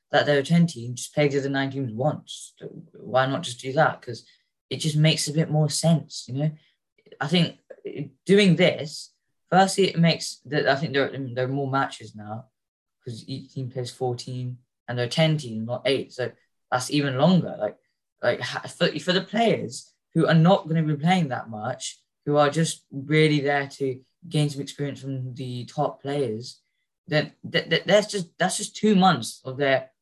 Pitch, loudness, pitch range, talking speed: 145 Hz, -24 LUFS, 130-165 Hz, 185 wpm